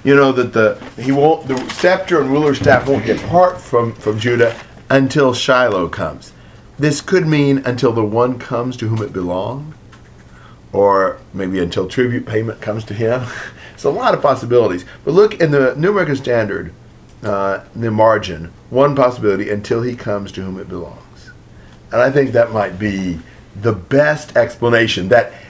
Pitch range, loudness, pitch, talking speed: 105-135 Hz, -15 LUFS, 120 Hz, 165 wpm